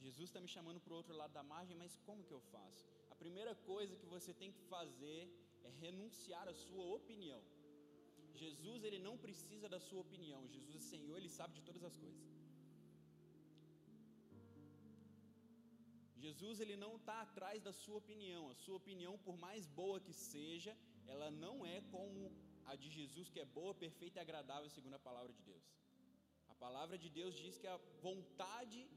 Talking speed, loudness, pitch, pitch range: 180 wpm, -55 LUFS, 175 Hz, 135-195 Hz